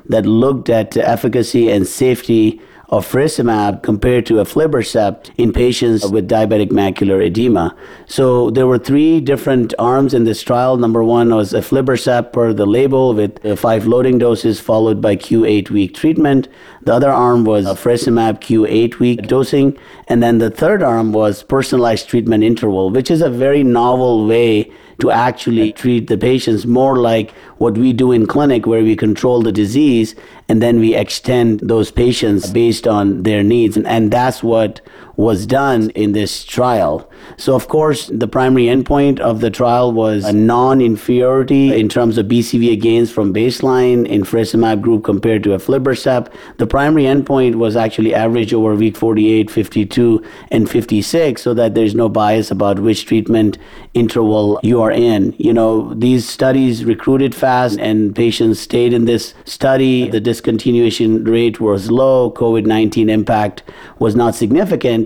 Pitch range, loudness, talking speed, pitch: 110-125 Hz, -13 LUFS, 160 wpm, 115 Hz